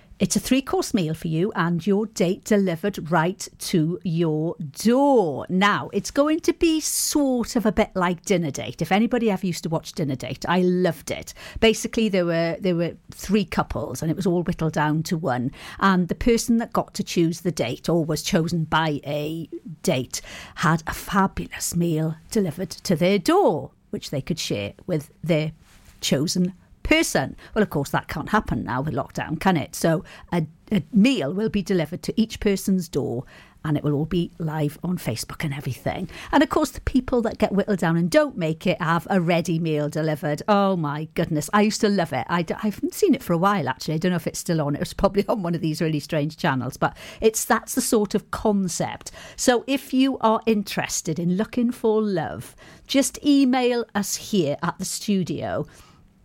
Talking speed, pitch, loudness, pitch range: 200 wpm, 180 Hz, -23 LUFS, 155-210 Hz